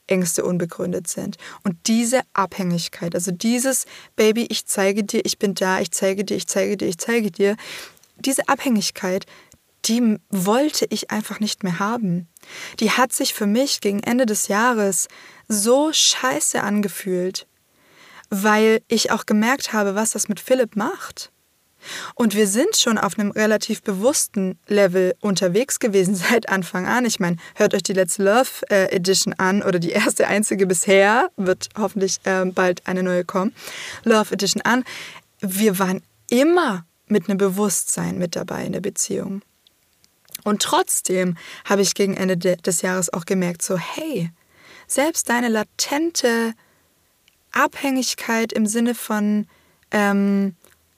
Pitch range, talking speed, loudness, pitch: 190-230 Hz, 145 wpm, -20 LUFS, 205 Hz